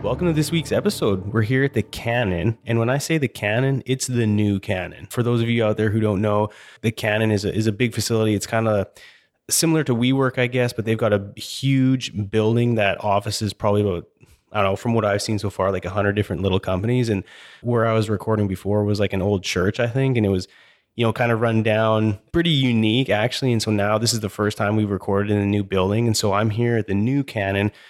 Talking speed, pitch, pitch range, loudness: 245 wpm, 110 Hz, 100-120 Hz, -21 LUFS